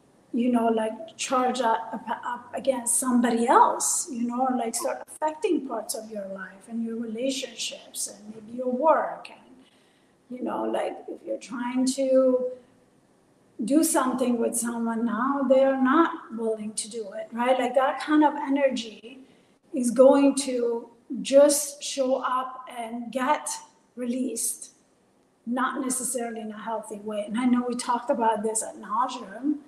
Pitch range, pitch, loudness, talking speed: 230-270 Hz, 250 Hz, -25 LUFS, 150 wpm